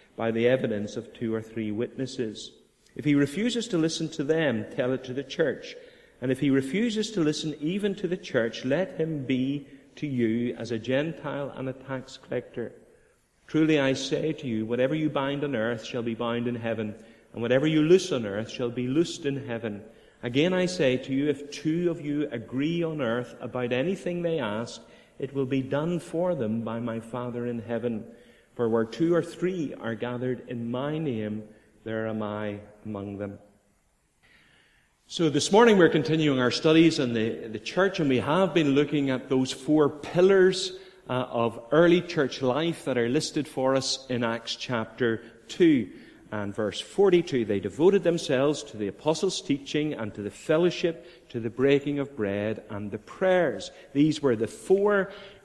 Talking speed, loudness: 185 wpm, -27 LUFS